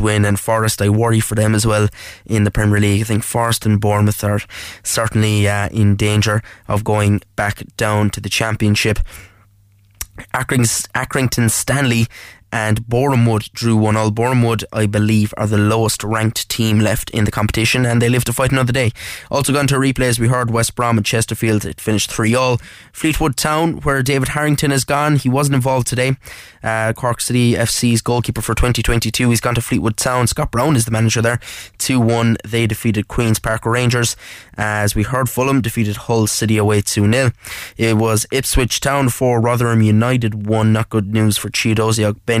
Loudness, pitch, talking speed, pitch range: -16 LUFS, 115 Hz, 185 wpm, 105-125 Hz